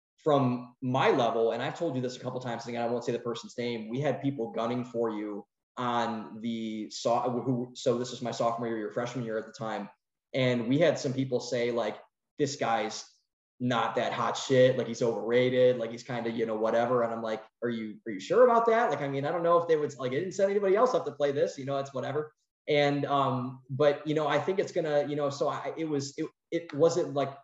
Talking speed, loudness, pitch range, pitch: 250 wpm, -29 LUFS, 115-145 Hz, 125 Hz